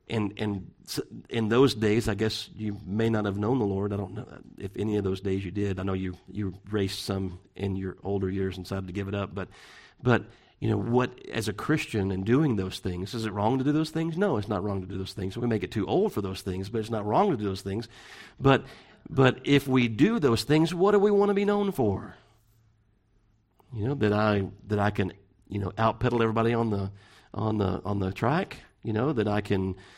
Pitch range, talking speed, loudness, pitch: 95-115 Hz, 245 wpm, -28 LUFS, 105 Hz